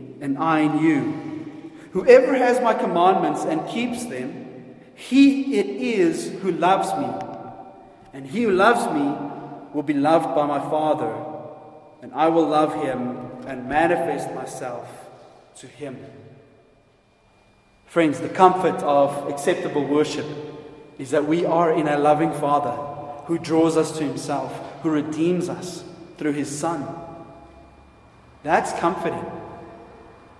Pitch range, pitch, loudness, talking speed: 145-170 Hz, 155 Hz, -21 LUFS, 130 wpm